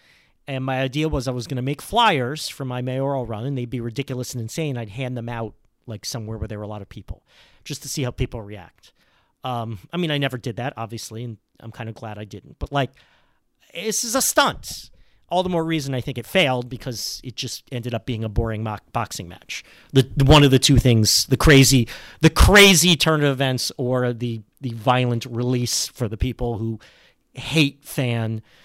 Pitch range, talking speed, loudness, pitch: 115-140 Hz, 215 wpm, -20 LUFS, 125 Hz